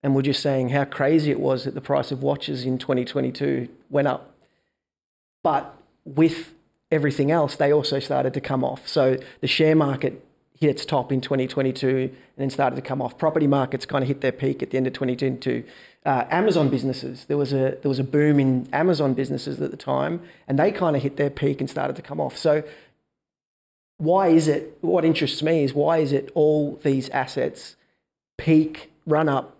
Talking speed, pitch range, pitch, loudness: 200 wpm, 135-155 Hz, 140 Hz, -23 LUFS